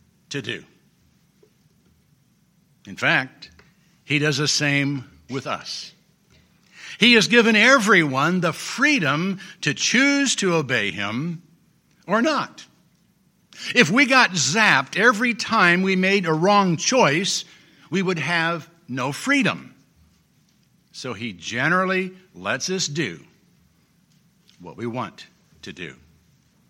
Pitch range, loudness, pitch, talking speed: 150-200 Hz, -19 LUFS, 175 Hz, 110 wpm